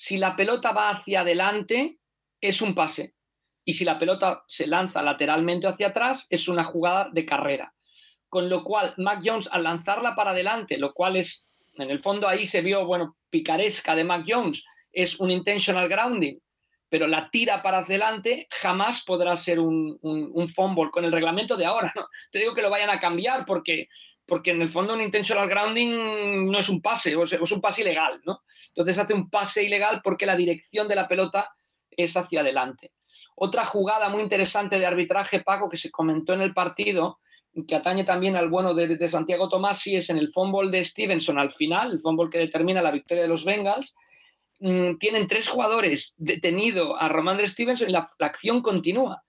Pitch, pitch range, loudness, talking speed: 190 Hz, 175-210 Hz, -24 LUFS, 200 wpm